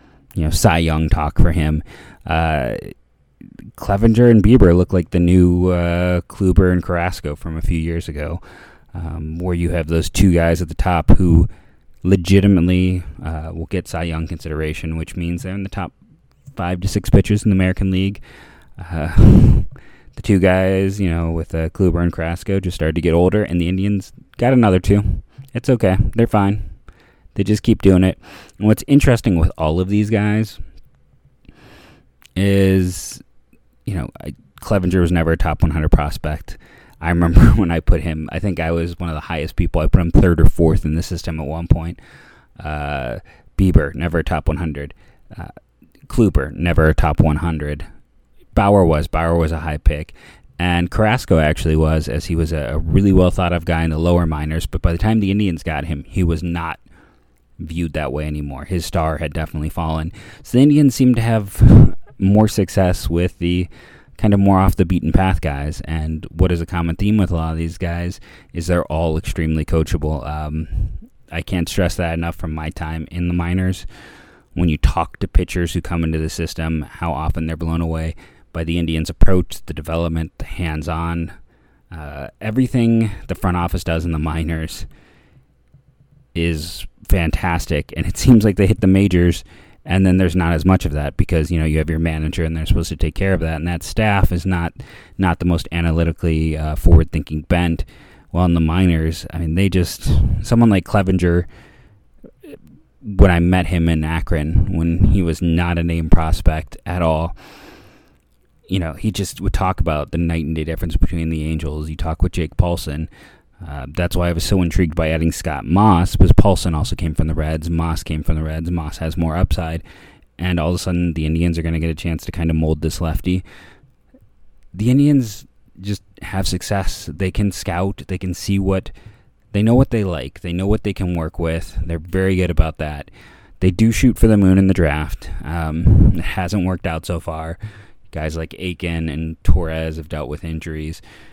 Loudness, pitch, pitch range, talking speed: -18 LUFS, 85 Hz, 80-95 Hz, 195 wpm